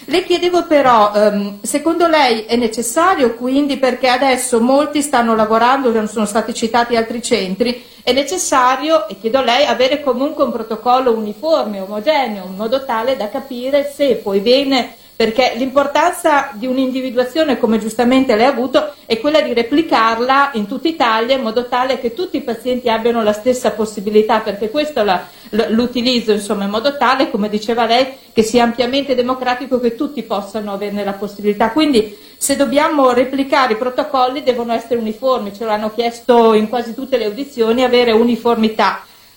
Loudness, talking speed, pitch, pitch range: -15 LUFS, 160 wpm, 245 Hz, 225-270 Hz